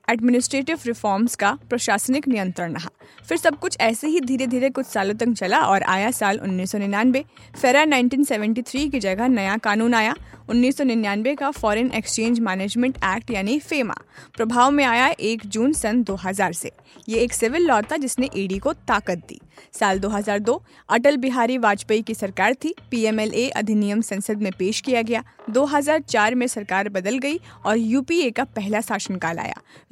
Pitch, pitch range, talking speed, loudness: 230 Hz, 205-260 Hz, 140 wpm, -21 LUFS